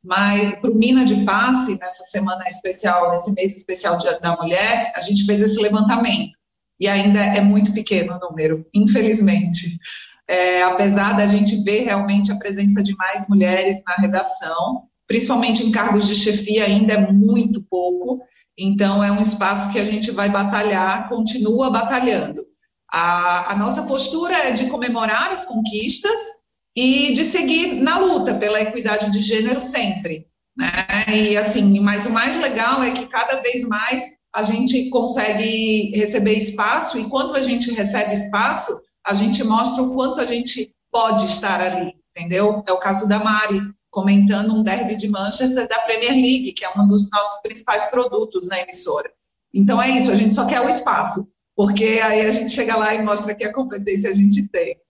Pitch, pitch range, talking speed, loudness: 215 Hz, 200-245 Hz, 175 wpm, -18 LUFS